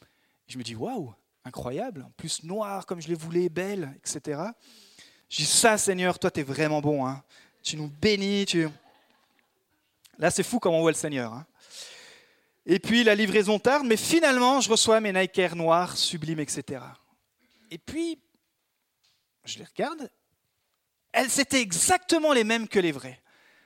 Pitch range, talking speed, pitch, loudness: 160-230 Hz, 160 wpm, 195 Hz, -25 LUFS